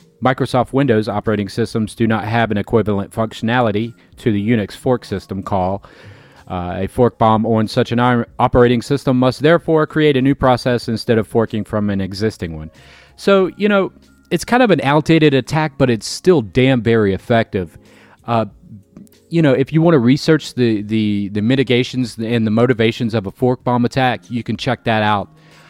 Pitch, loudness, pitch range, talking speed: 120 Hz, -16 LUFS, 105-135 Hz, 185 wpm